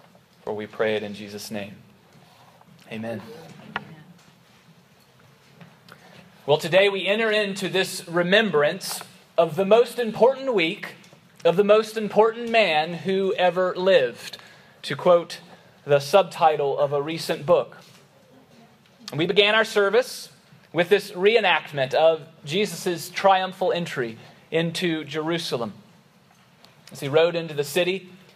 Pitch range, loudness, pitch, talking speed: 155-195 Hz, -22 LUFS, 175 Hz, 115 wpm